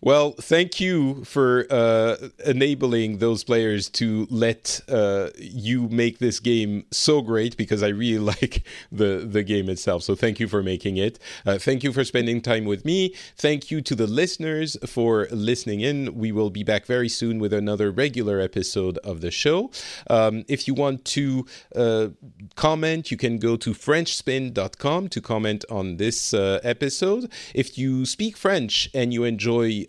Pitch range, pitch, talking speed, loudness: 105-135 Hz, 115 Hz, 170 wpm, -23 LUFS